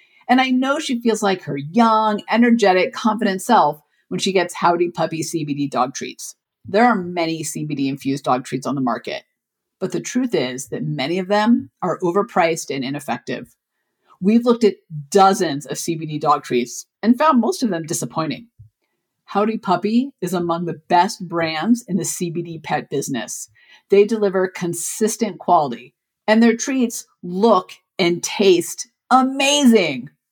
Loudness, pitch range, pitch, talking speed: -19 LUFS, 160-225 Hz, 185 Hz, 155 wpm